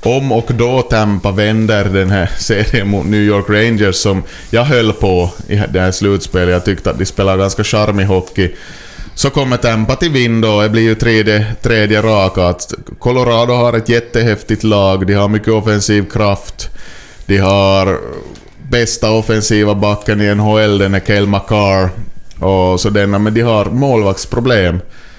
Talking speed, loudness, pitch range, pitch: 160 wpm, -12 LUFS, 95-110 Hz, 105 Hz